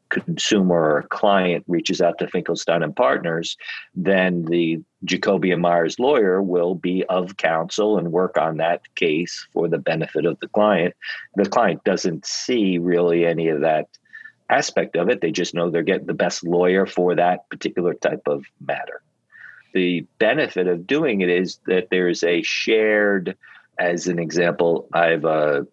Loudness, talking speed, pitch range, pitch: -20 LUFS, 165 wpm, 85-95 Hz, 90 Hz